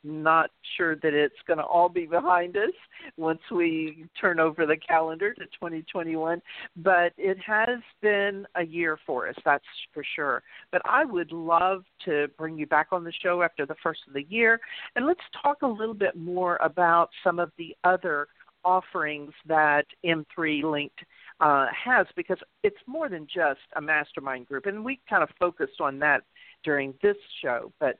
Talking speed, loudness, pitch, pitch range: 180 wpm, -26 LUFS, 170 Hz, 155-195 Hz